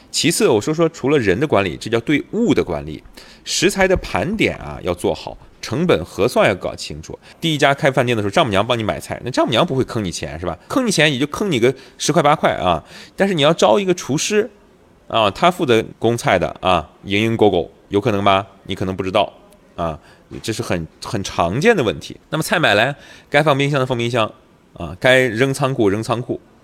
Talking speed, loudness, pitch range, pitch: 310 characters per minute, -18 LUFS, 110-155 Hz, 130 Hz